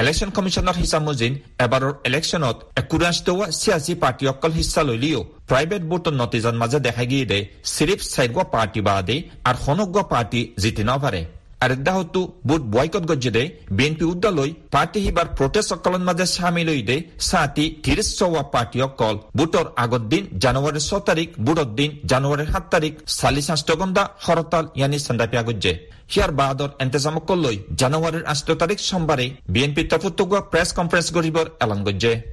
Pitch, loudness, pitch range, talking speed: 150 Hz, -21 LUFS, 125-170 Hz, 120 wpm